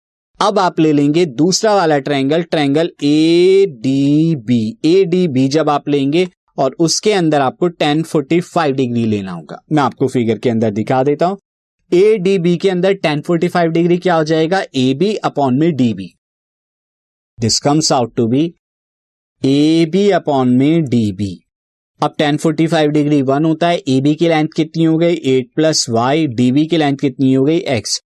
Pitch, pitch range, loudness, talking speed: 155 Hz, 135-170 Hz, -14 LUFS, 185 wpm